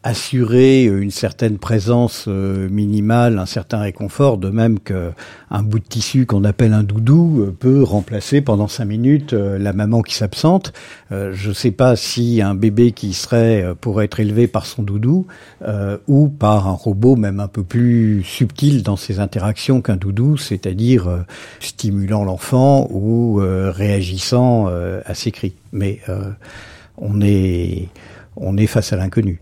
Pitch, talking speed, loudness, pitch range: 105 Hz, 145 wpm, -16 LUFS, 100-120 Hz